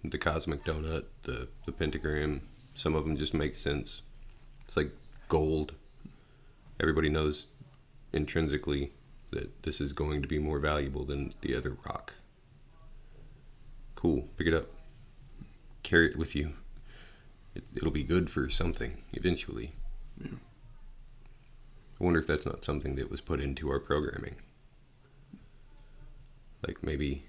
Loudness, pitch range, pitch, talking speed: -33 LUFS, 75-90 Hz, 80 Hz, 130 wpm